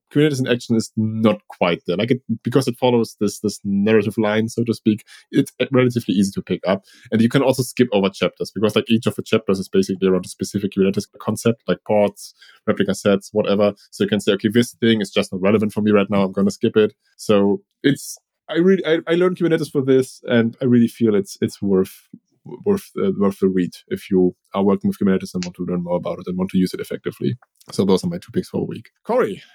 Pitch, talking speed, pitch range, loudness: 105 Hz, 245 wpm, 100-120 Hz, -20 LUFS